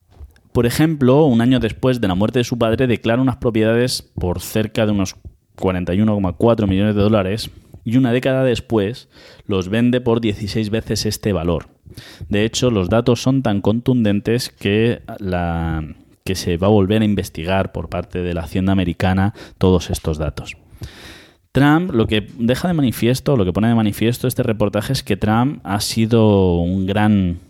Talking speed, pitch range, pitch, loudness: 170 wpm, 95-115 Hz, 105 Hz, -18 LUFS